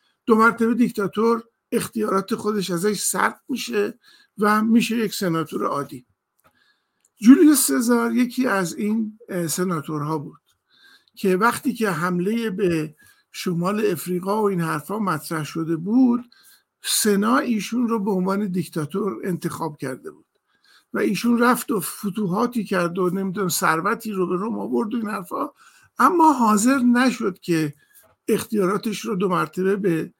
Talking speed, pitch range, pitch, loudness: 135 wpm, 180-235 Hz, 210 Hz, -21 LUFS